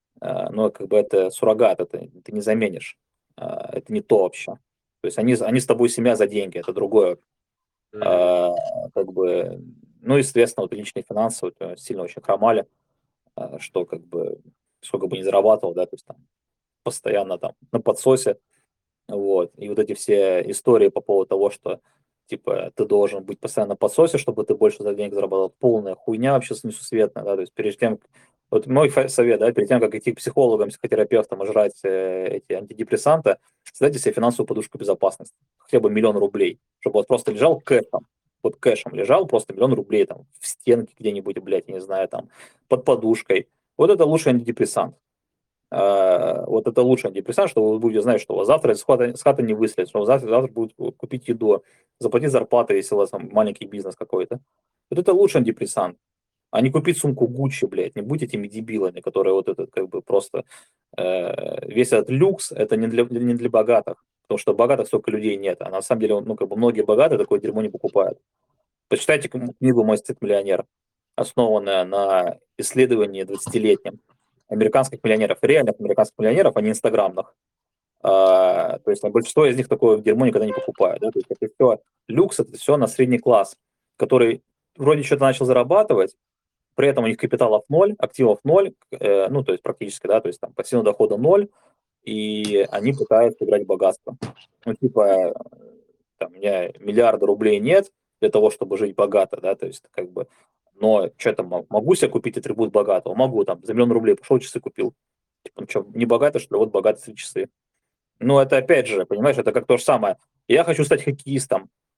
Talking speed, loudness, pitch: 185 wpm, -20 LUFS, 340 Hz